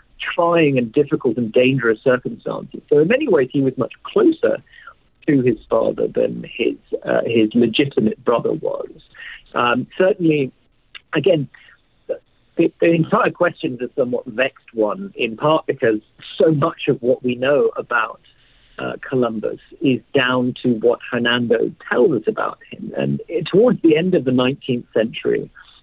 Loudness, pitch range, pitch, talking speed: -18 LUFS, 125-180 Hz, 140 Hz, 155 wpm